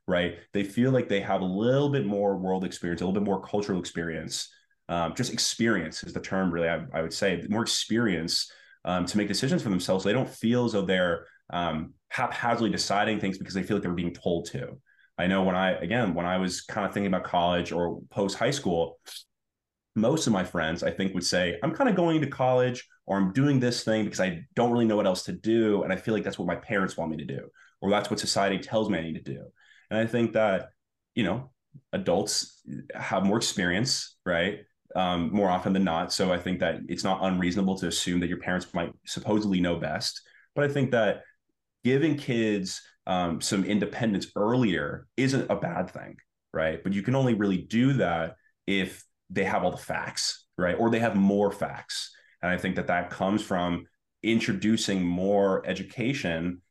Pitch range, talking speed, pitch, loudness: 90-115 Hz, 210 wpm, 95 Hz, -27 LUFS